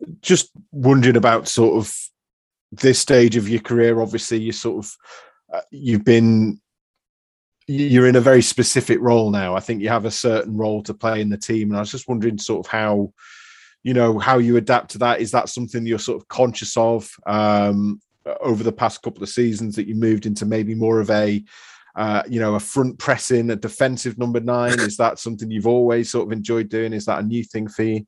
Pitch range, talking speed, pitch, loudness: 110-120 Hz, 215 wpm, 115 Hz, -19 LUFS